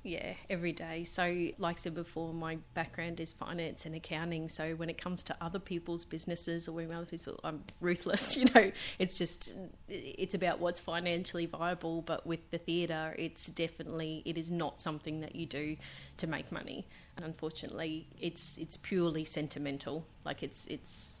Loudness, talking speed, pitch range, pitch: -36 LUFS, 175 wpm, 160-175 Hz, 165 Hz